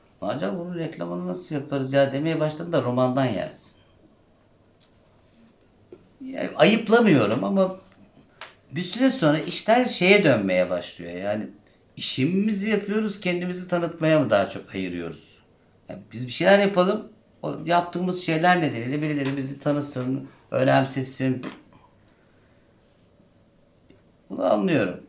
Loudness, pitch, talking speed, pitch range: -23 LUFS, 155 Hz, 110 wpm, 130-180 Hz